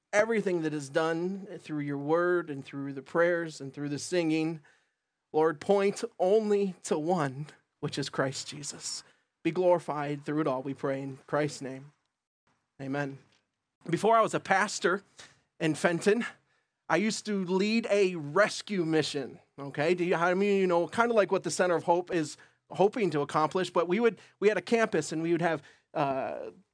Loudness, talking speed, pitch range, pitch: -29 LUFS, 175 wpm, 145-190 Hz, 165 Hz